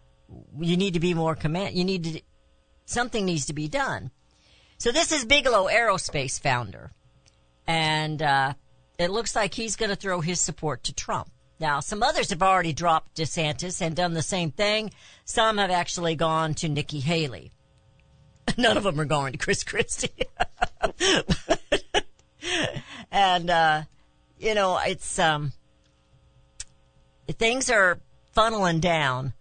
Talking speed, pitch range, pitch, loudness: 145 wpm, 145-190 Hz, 160 Hz, -25 LUFS